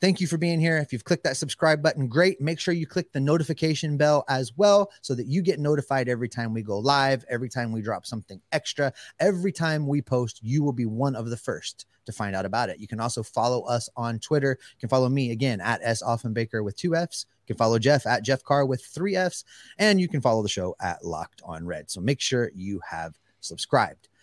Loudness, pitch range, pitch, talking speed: -25 LUFS, 115-155 Hz, 135 Hz, 240 wpm